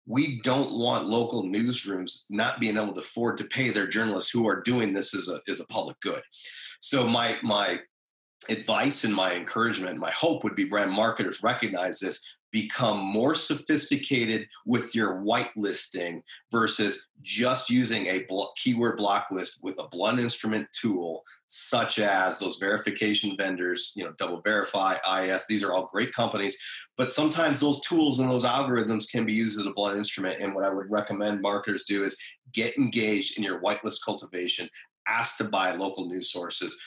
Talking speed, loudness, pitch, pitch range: 175 wpm, -27 LUFS, 110 Hz, 100-125 Hz